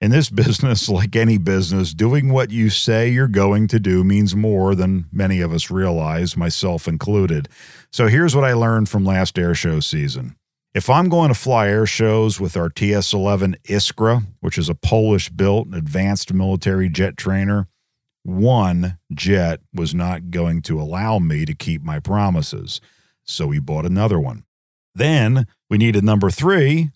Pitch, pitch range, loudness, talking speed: 100 Hz, 85-110 Hz, -18 LUFS, 165 wpm